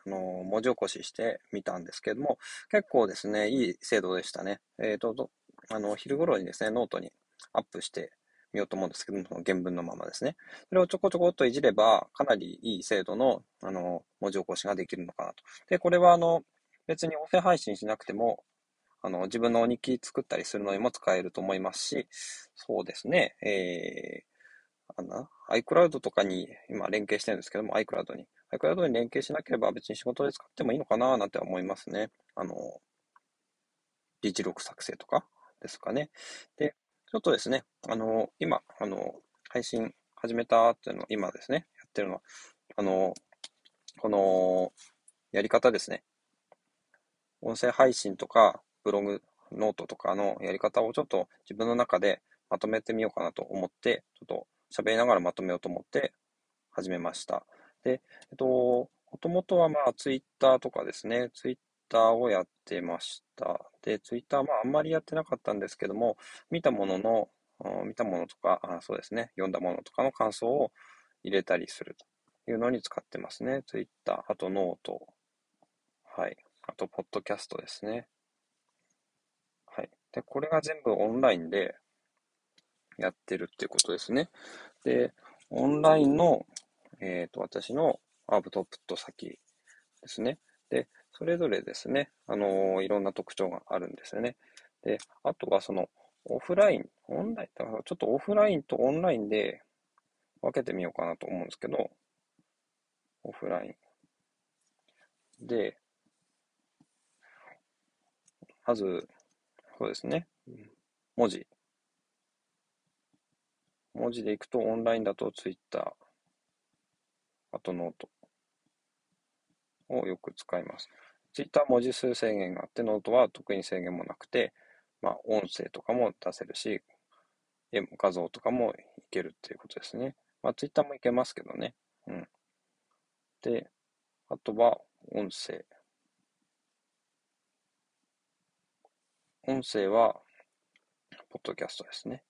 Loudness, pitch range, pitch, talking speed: -31 LUFS, 100-135 Hz, 115 Hz, 305 characters per minute